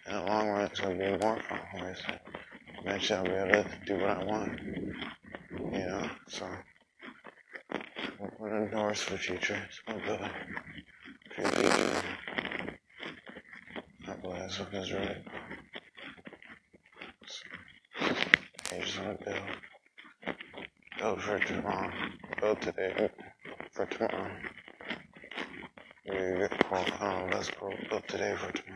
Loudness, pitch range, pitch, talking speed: -34 LUFS, 95-105 Hz, 100 Hz, 100 wpm